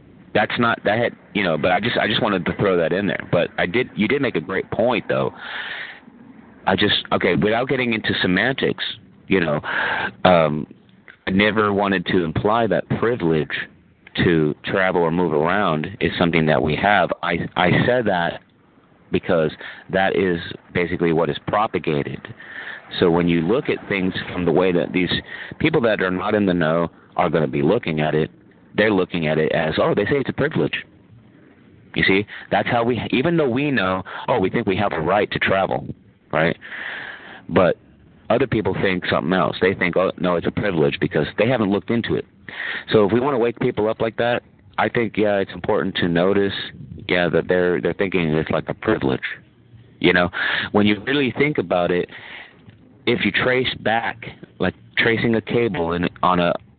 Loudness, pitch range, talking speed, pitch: -20 LUFS, 85-110 Hz, 195 wpm, 95 Hz